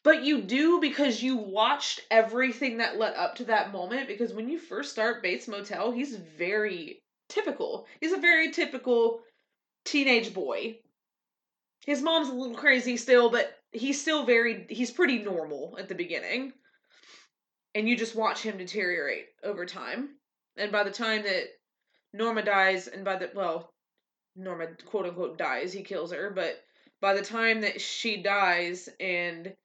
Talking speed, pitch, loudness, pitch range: 160 wpm, 230 Hz, -28 LUFS, 200-285 Hz